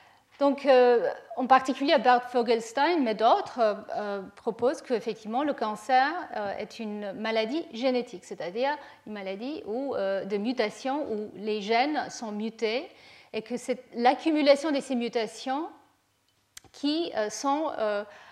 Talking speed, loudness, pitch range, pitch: 135 wpm, -27 LUFS, 215-275 Hz, 245 Hz